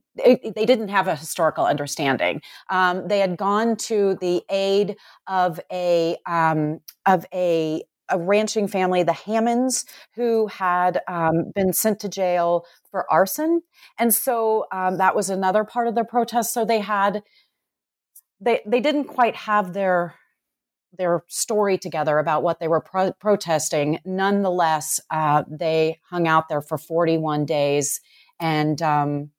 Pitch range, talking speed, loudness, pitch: 160-210 Hz, 145 wpm, -22 LUFS, 185 Hz